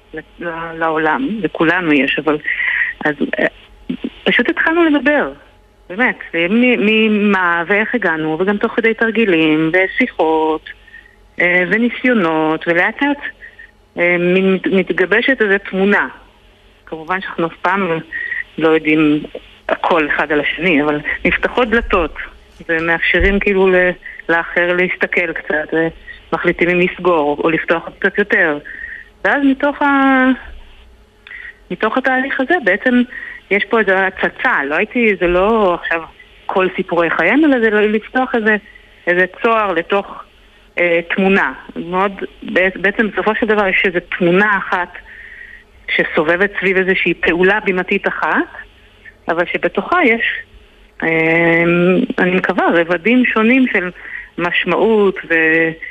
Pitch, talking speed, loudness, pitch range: 190 Hz, 110 wpm, -14 LUFS, 170-235 Hz